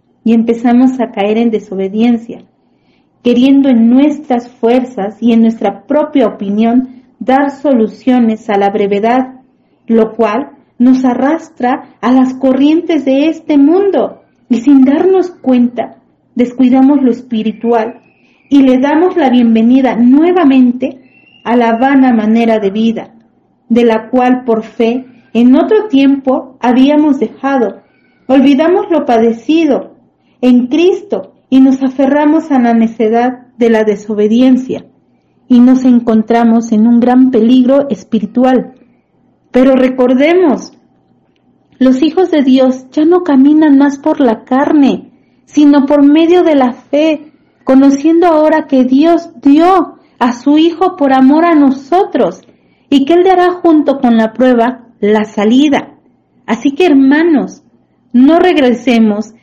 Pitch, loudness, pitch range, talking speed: 255 Hz, -9 LUFS, 235-290 Hz, 130 wpm